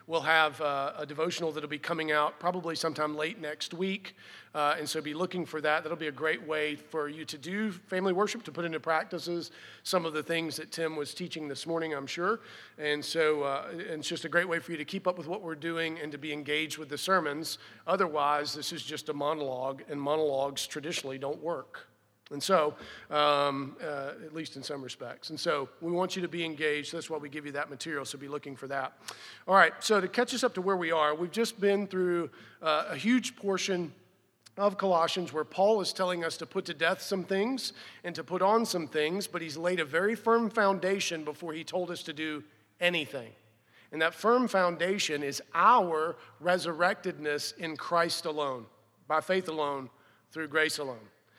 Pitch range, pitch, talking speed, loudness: 150-180 Hz, 160 Hz, 210 wpm, -31 LUFS